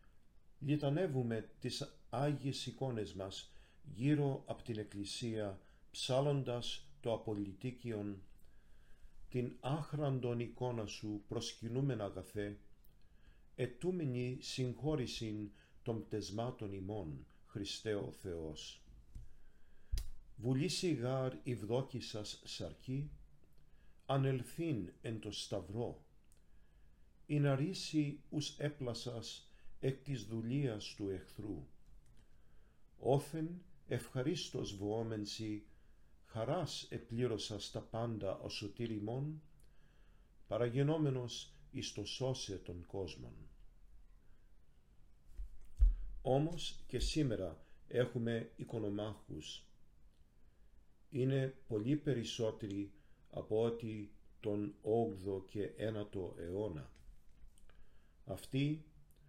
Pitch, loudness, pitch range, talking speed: 115 Hz, -41 LUFS, 95-130 Hz, 75 wpm